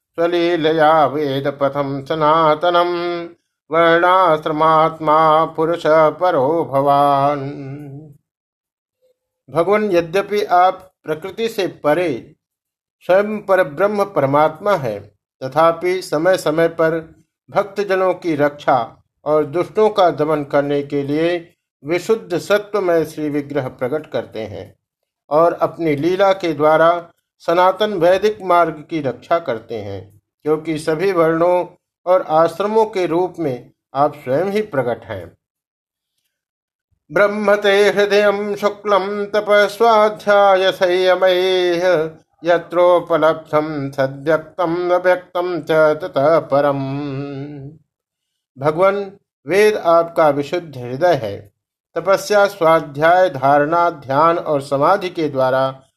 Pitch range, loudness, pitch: 150-185 Hz, -16 LUFS, 165 Hz